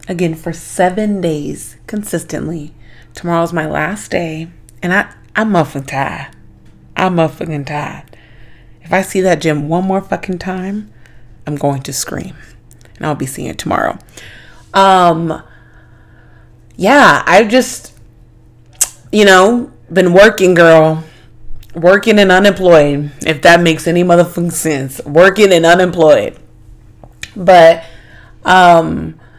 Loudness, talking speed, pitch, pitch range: -11 LUFS, 120 wpm, 160 Hz, 120-180 Hz